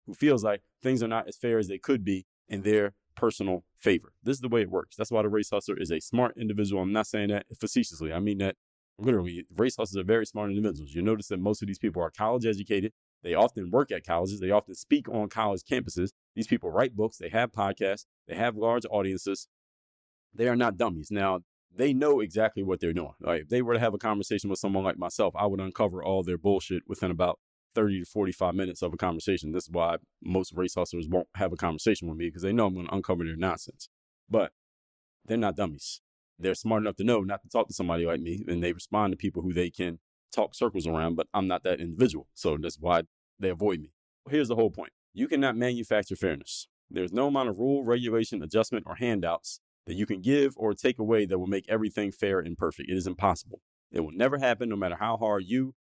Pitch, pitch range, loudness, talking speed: 100 Hz, 90-110 Hz, -29 LUFS, 235 wpm